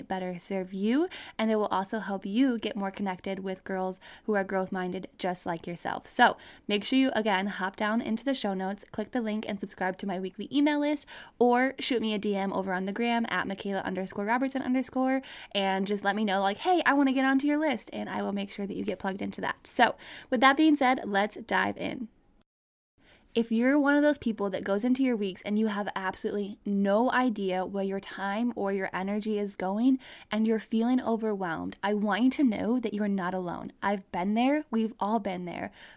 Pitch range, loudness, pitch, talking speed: 195-250 Hz, -29 LUFS, 210 Hz, 220 wpm